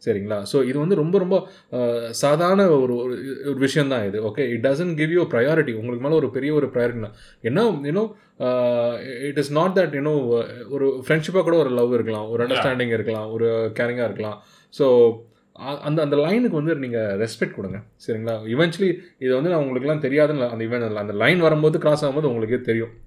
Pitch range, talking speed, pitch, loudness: 115-155 Hz, 170 wpm, 135 Hz, -21 LUFS